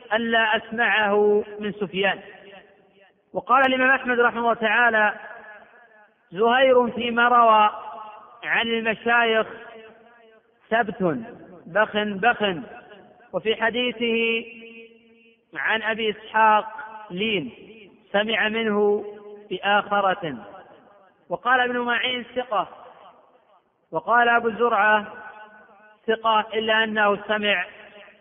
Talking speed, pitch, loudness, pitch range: 80 wpm, 220 Hz, -21 LUFS, 205-230 Hz